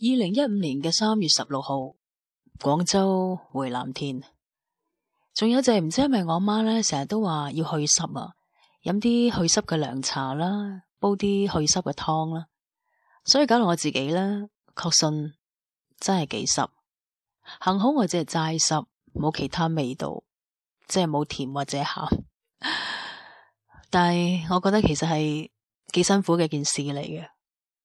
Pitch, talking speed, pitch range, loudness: 170 Hz, 215 characters per minute, 150-205 Hz, -24 LUFS